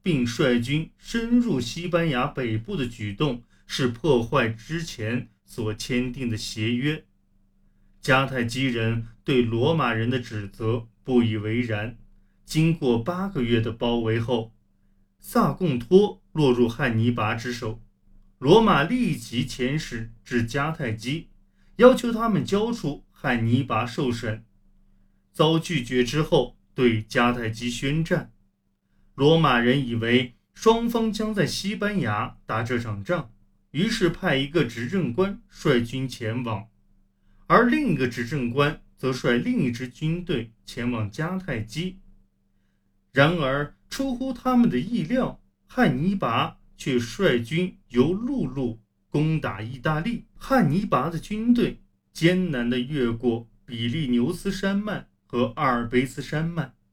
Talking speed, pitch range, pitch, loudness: 195 characters per minute, 115-165 Hz, 125 Hz, -24 LUFS